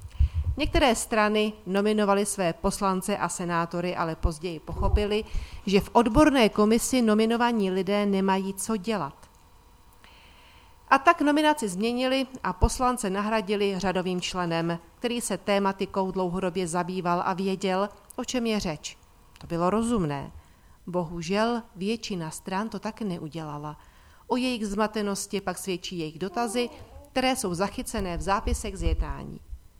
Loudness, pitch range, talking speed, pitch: -27 LUFS, 175-220 Hz, 125 wpm, 195 Hz